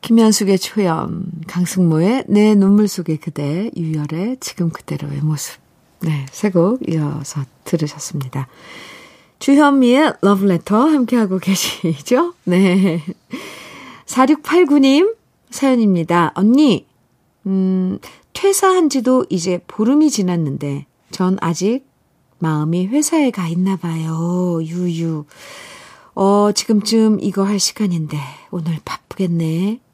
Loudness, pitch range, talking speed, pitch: -16 LUFS, 165-230 Hz, 225 characters per minute, 185 Hz